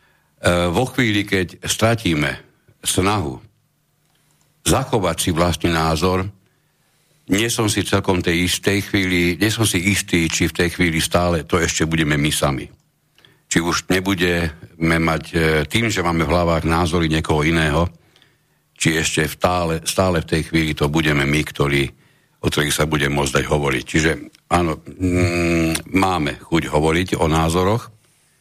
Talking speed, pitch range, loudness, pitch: 150 wpm, 80-95 Hz, -19 LUFS, 85 Hz